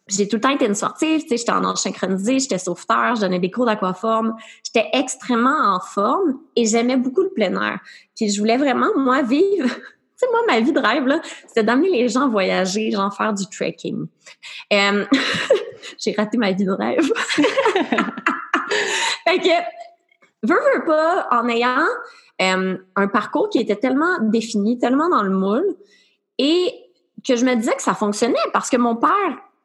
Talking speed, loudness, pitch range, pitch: 180 wpm, -19 LUFS, 215-340 Hz, 250 Hz